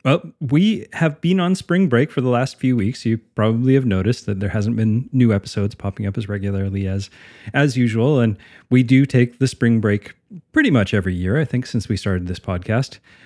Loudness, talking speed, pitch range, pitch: -19 LUFS, 215 wpm, 105-135 Hz, 120 Hz